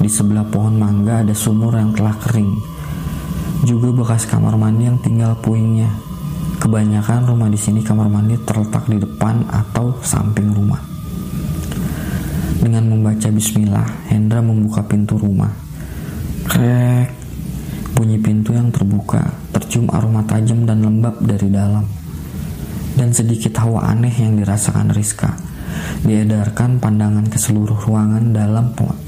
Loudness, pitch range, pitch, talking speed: -16 LUFS, 105-115 Hz, 110 Hz, 125 wpm